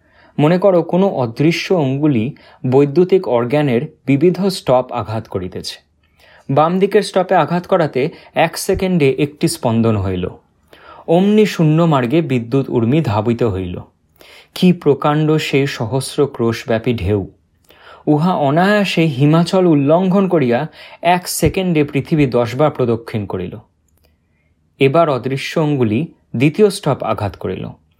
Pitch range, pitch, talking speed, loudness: 120-170 Hz, 145 Hz, 110 wpm, -15 LUFS